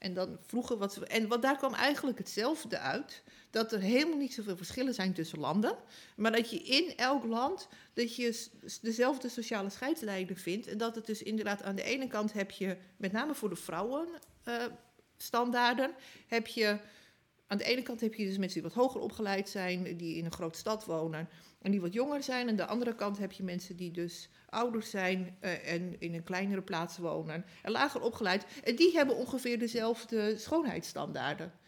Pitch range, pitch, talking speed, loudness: 185-245 Hz, 220 Hz, 190 wpm, -35 LUFS